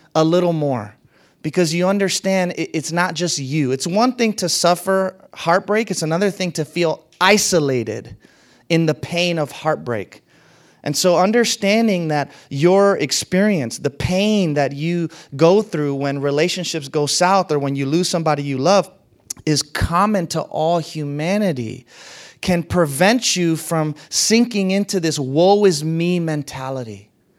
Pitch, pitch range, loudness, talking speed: 165 Hz, 145-185 Hz, -18 LUFS, 145 wpm